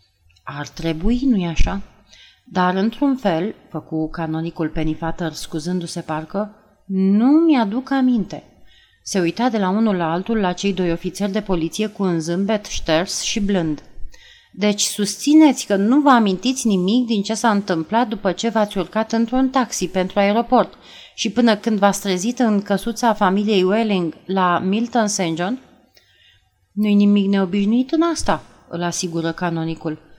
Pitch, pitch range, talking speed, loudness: 200 Hz, 170-225 Hz, 145 wpm, -19 LUFS